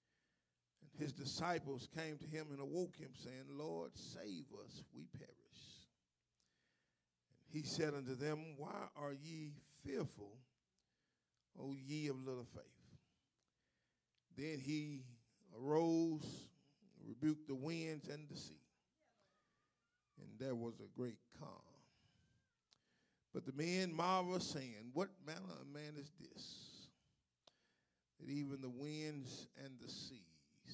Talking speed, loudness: 125 wpm, -47 LUFS